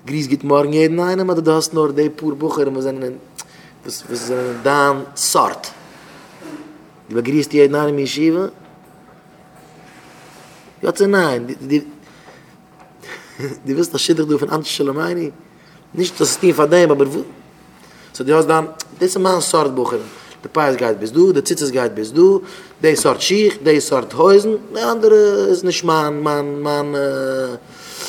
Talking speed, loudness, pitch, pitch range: 155 wpm, -16 LUFS, 150 Hz, 140-175 Hz